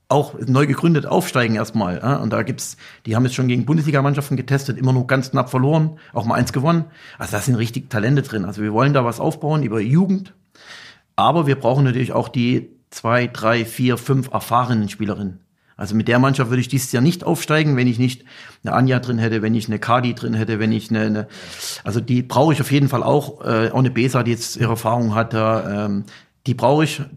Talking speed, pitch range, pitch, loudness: 220 wpm, 115-140 Hz, 125 Hz, -19 LUFS